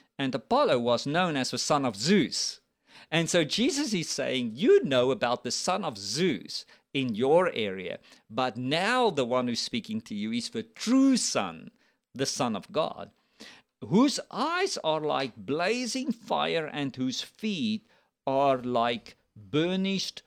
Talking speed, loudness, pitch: 155 wpm, -28 LUFS, 165 Hz